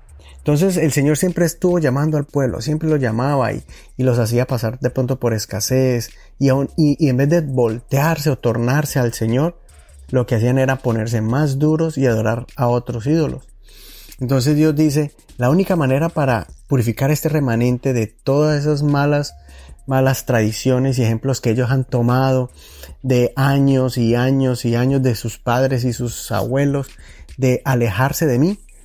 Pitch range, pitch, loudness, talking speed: 120-145 Hz, 130 Hz, -18 LUFS, 170 wpm